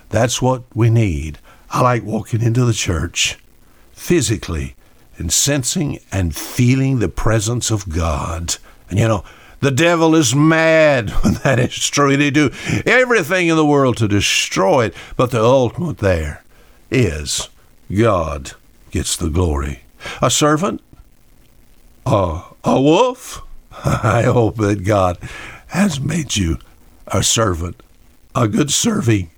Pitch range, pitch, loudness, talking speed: 90-145 Hz, 115 Hz, -16 LUFS, 135 wpm